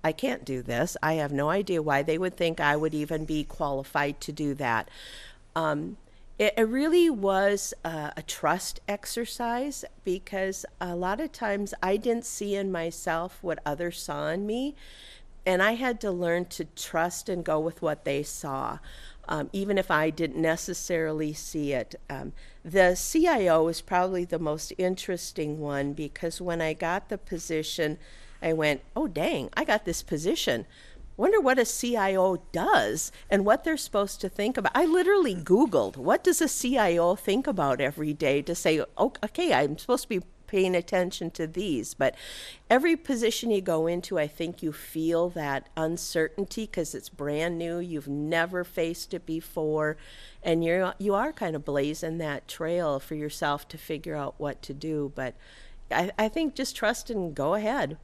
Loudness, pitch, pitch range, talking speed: -28 LUFS, 170 Hz, 155-200 Hz, 175 wpm